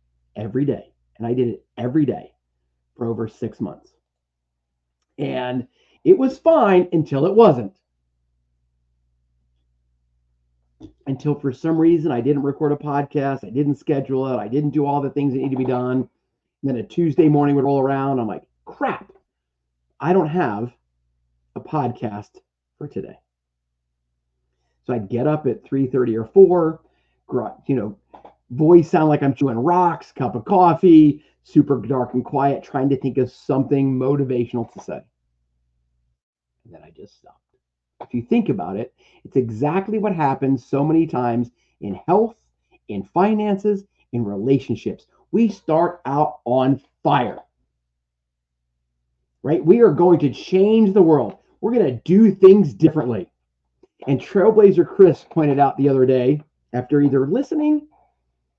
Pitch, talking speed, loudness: 130 Hz, 150 wpm, -18 LUFS